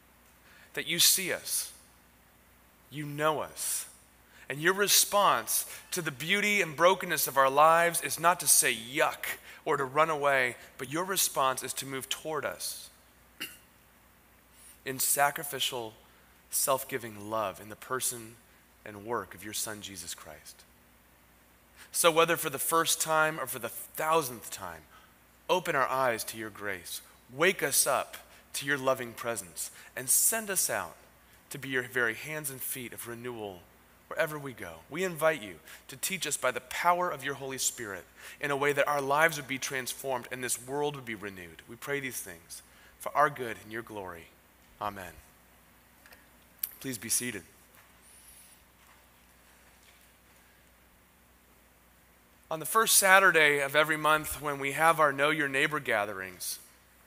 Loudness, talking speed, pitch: -29 LUFS, 155 wpm, 120 Hz